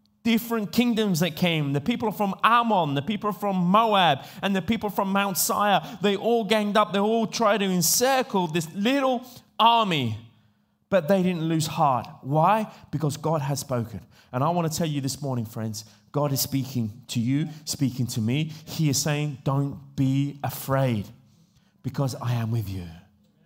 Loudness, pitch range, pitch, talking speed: -24 LUFS, 135-205 Hz, 160 Hz, 175 wpm